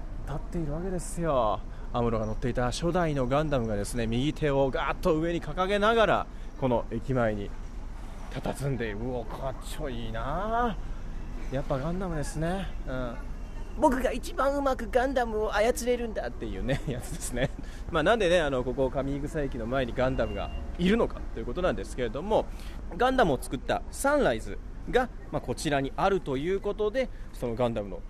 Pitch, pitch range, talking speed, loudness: 135 Hz, 120-185 Hz, 380 characters per minute, -29 LUFS